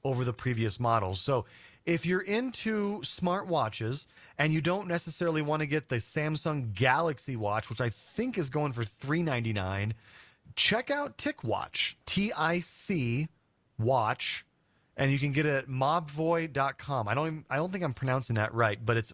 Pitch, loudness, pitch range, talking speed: 140 Hz, -31 LUFS, 120-165 Hz, 165 wpm